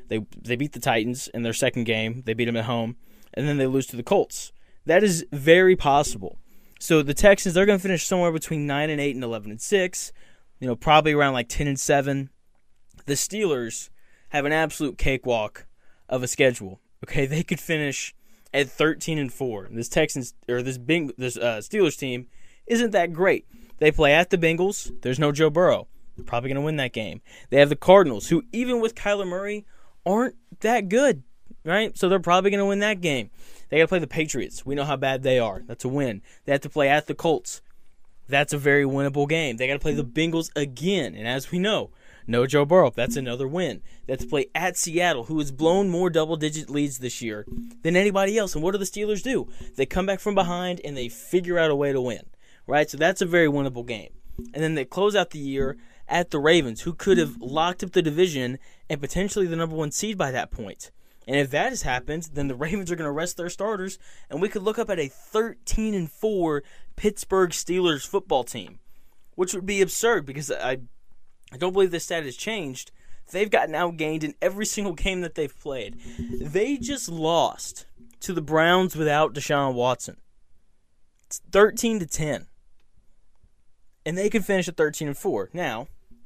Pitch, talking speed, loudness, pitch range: 155 Hz, 210 wpm, -24 LUFS, 130-185 Hz